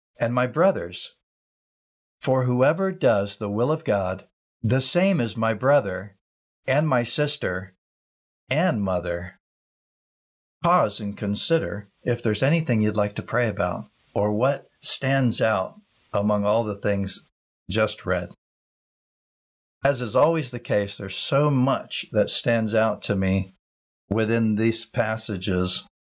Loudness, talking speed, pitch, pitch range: -23 LUFS, 130 wpm, 110 Hz, 100-130 Hz